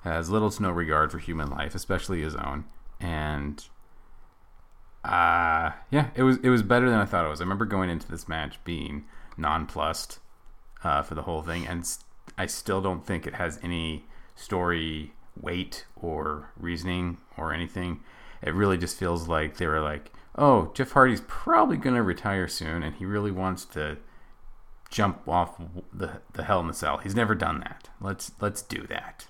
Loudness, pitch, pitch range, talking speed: -28 LUFS, 85 Hz, 80-95 Hz, 185 wpm